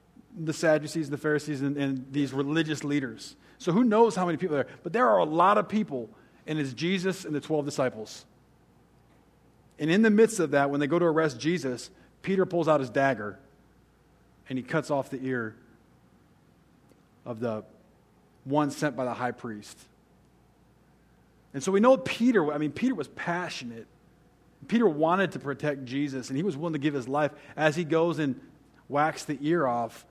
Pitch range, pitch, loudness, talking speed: 130-165 Hz, 145 Hz, -27 LUFS, 185 wpm